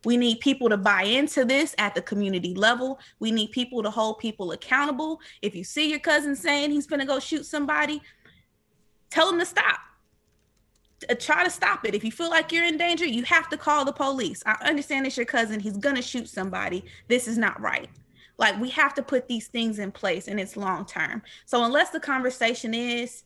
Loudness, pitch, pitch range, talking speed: -25 LUFS, 250 Hz, 220-295 Hz, 215 wpm